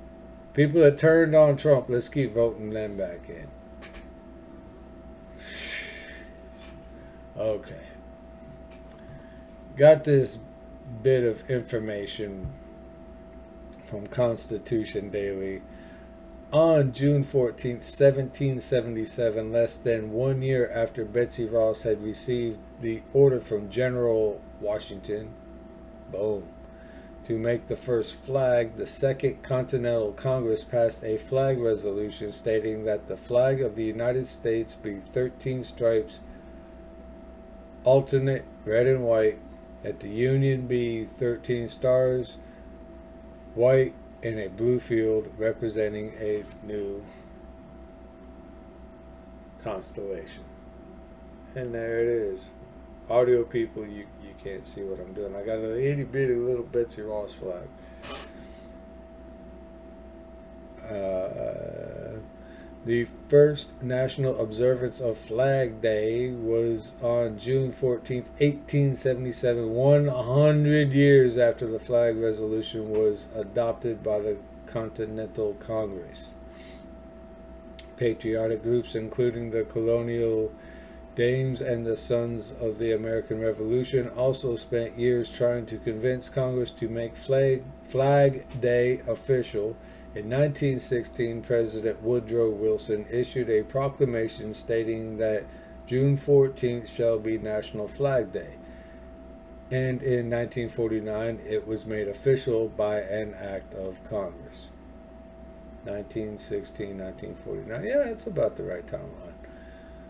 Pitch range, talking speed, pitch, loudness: 100-125 Hz, 105 wpm, 115 Hz, -26 LUFS